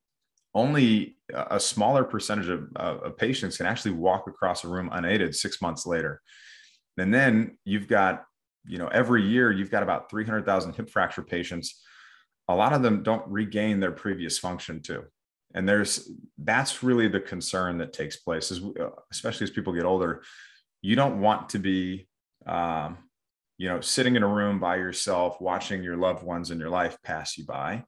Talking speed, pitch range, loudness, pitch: 175 wpm, 90-105 Hz, -27 LUFS, 95 Hz